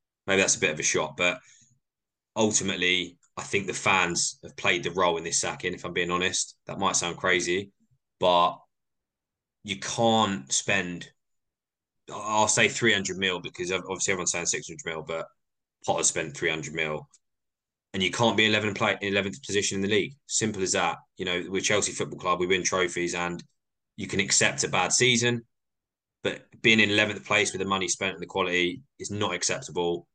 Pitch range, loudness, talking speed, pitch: 90-110 Hz, -25 LUFS, 180 wpm, 95 Hz